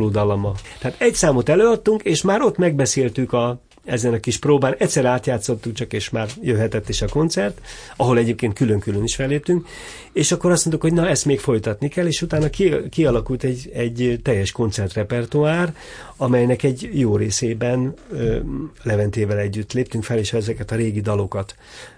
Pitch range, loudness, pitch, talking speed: 110-150 Hz, -20 LUFS, 125 Hz, 165 wpm